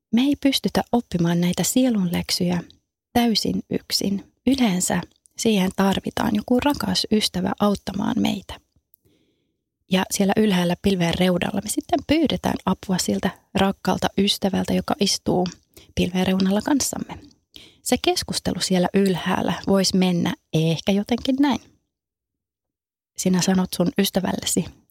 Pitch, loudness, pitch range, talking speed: 195 Hz, -22 LUFS, 185-230 Hz, 110 wpm